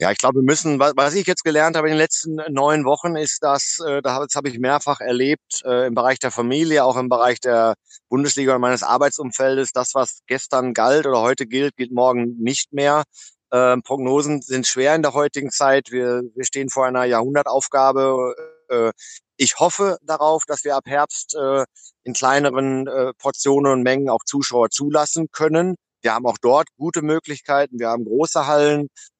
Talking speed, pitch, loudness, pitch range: 175 wpm, 140 Hz, -19 LUFS, 130-150 Hz